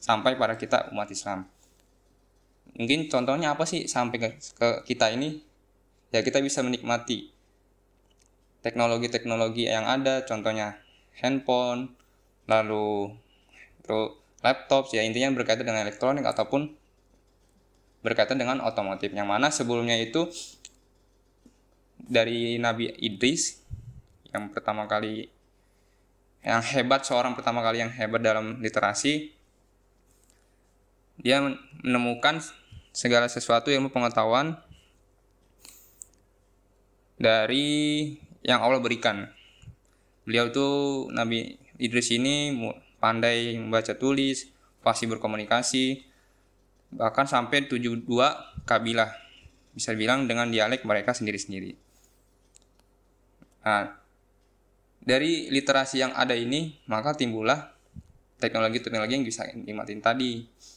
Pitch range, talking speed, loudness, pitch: 100-130 Hz, 95 wpm, -26 LUFS, 115 Hz